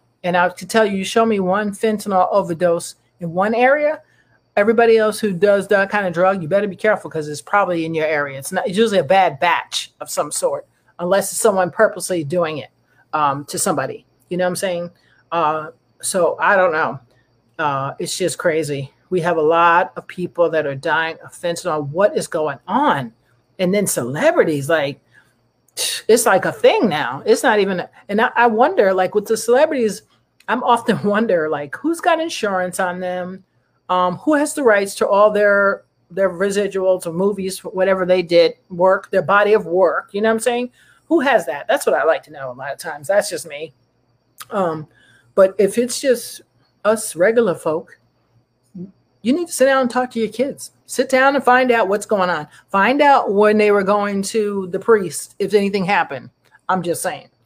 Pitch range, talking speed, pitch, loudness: 170-220 Hz, 200 wpm, 190 Hz, -17 LUFS